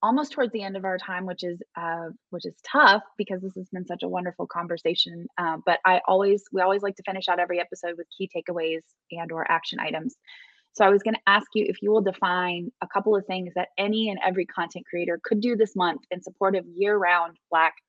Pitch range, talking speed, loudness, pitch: 175-200 Hz, 235 wpm, -25 LUFS, 185 Hz